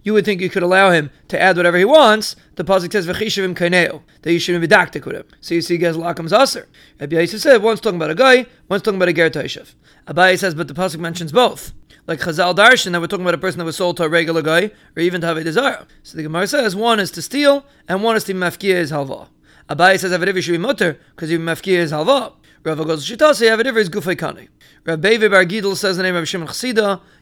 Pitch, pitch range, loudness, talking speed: 185 Hz, 170-210 Hz, -16 LUFS, 245 wpm